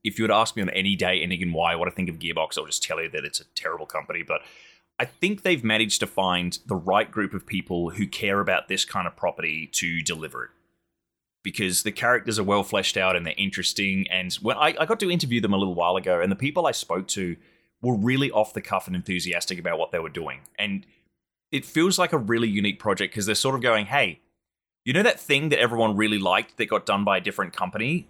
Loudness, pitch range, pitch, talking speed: -24 LUFS, 90-115 Hz, 100 Hz, 250 wpm